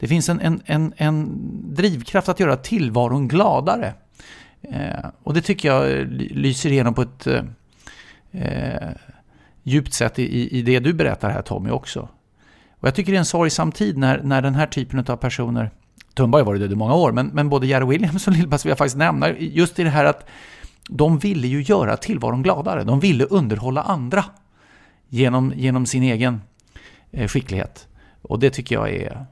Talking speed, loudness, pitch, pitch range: 185 wpm, -20 LUFS, 140 Hz, 125-165 Hz